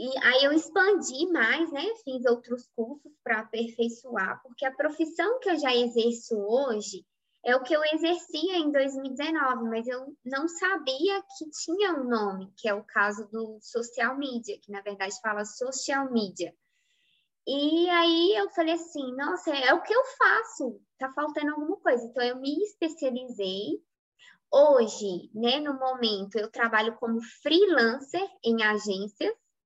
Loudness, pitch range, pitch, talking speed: -27 LUFS, 230-330 Hz, 265 Hz, 155 wpm